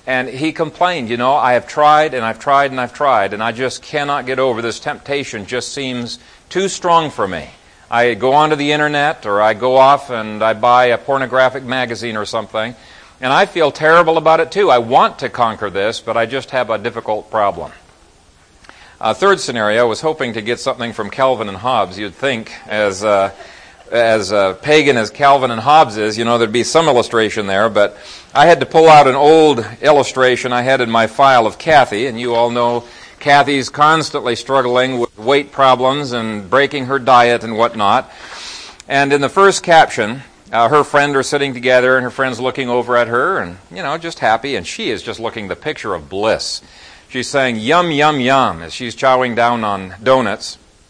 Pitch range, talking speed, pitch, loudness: 115-140 Hz, 200 wpm, 130 Hz, -14 LUFS